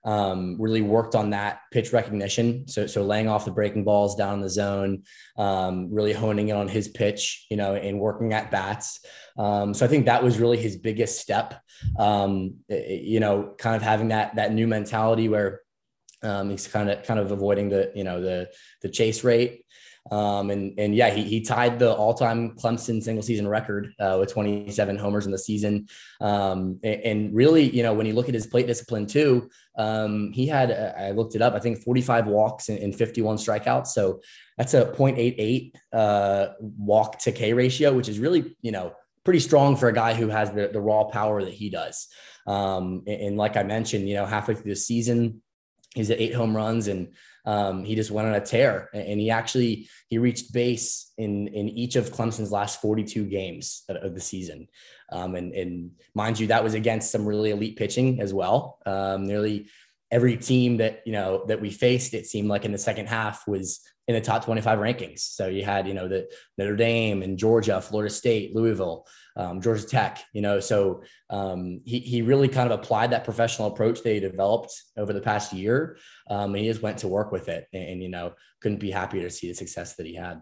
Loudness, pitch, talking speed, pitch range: -25 LUFS, 105 Hz, 210 wpm, 100-115 Hz